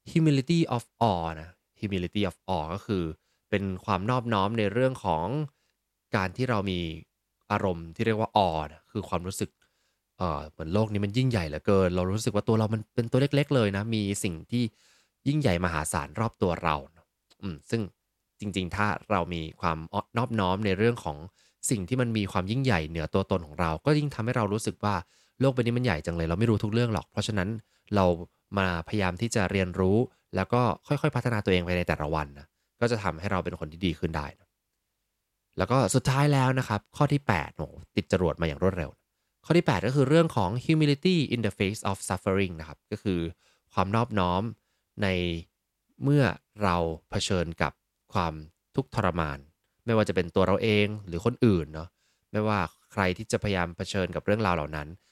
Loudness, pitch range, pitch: -28 LUFS, 90-115 Hz, 100 Hz